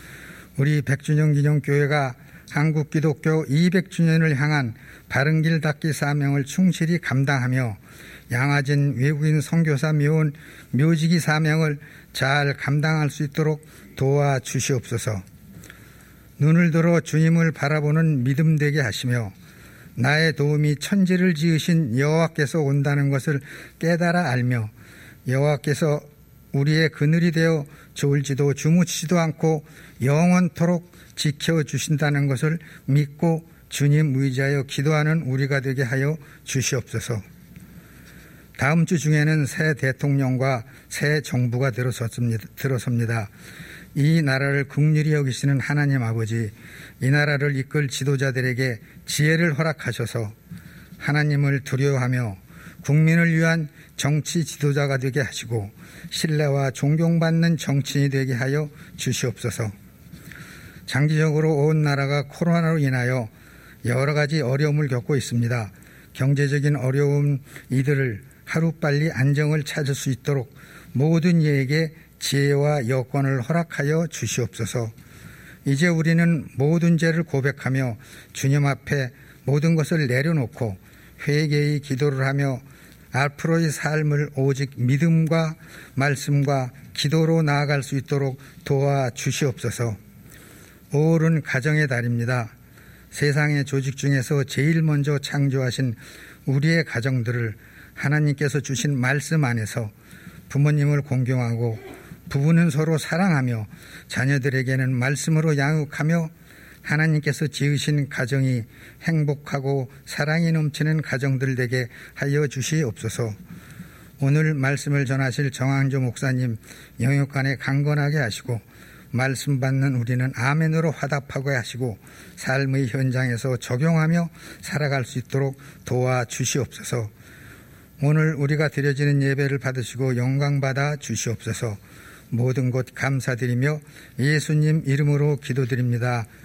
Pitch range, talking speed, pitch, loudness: 130-155 Hz, 280 characters per minute, 145 Hz, -22 LUFS